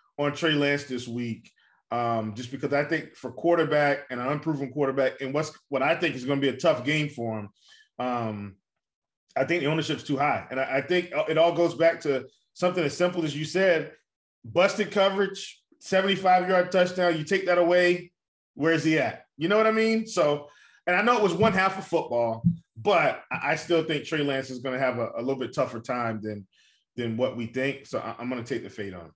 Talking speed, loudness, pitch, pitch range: 230 wpm, -26 LUFS, 150 Hz, 125-175 Hz